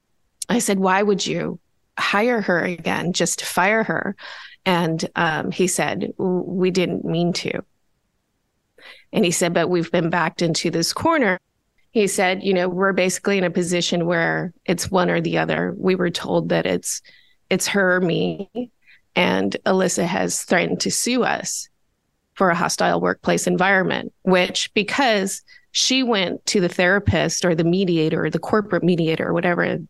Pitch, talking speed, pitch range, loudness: 180 Hz, 165 wpm, 170-200 Hz, -20 LUFS